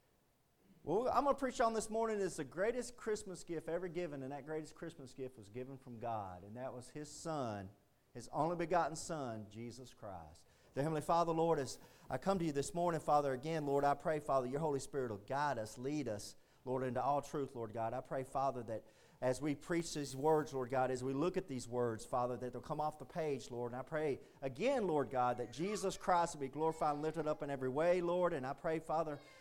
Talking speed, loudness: 230 wpm, -39 LUFS